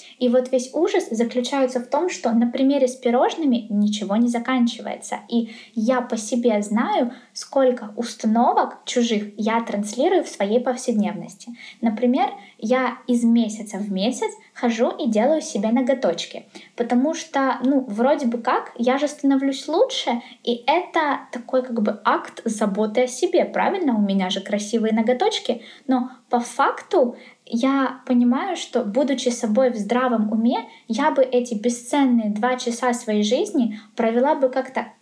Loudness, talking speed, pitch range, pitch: -21 LUFS, 145 wpm, 230-265 Hz, 245 Hz